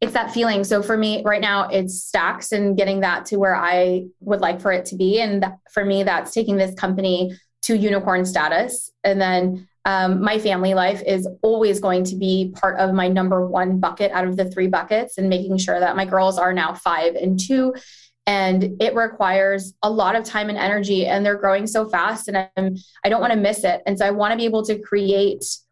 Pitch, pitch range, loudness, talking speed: 195 Hz, 185-210 Hz, -20 LUFS, 225 wpm